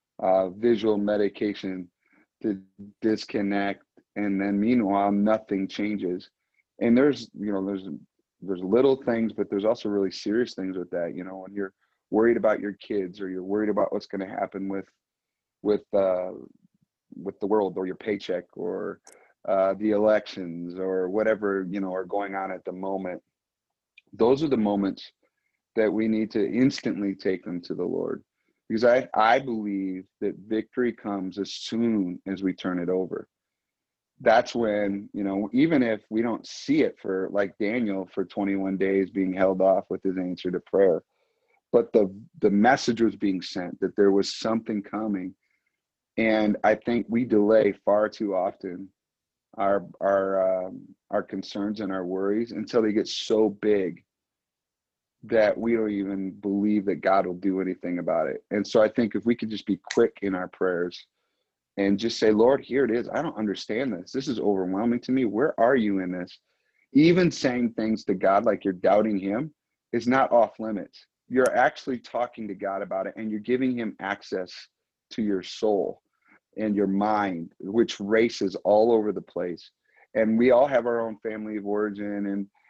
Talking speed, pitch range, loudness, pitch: 175 wpm, 95-110 Hz, -26 LUFS, 100 Hz